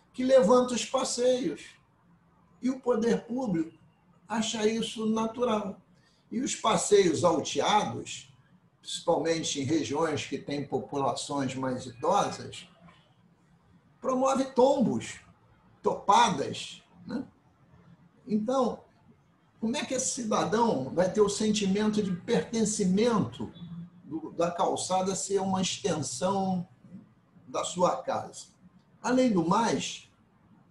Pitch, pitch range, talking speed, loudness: 195 Hz, 165-235 Hz, 100 wpm, -28 LUFS